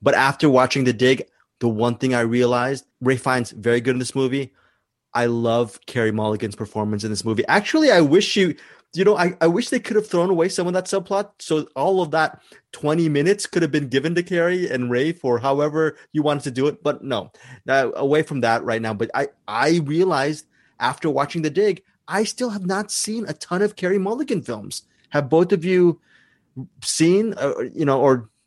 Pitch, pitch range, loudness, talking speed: 150 Hz, 125-180 Hz, -20 LUFS, 210 wpm